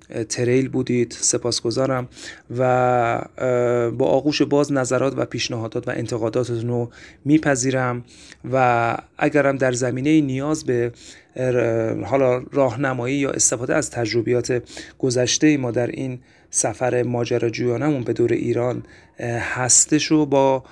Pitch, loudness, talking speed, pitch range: 125 Hz, -20 LUFS, 115 wpm, 120-135 Hz